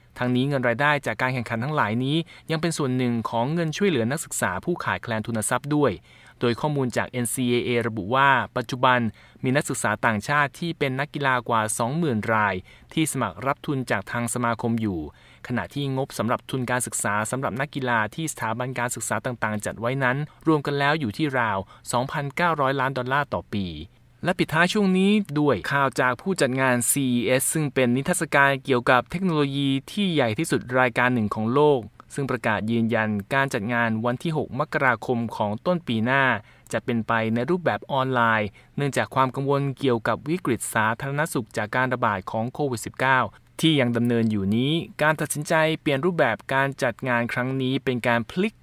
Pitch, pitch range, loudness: 130 Hz, 115-145 Hz, -24 LUFS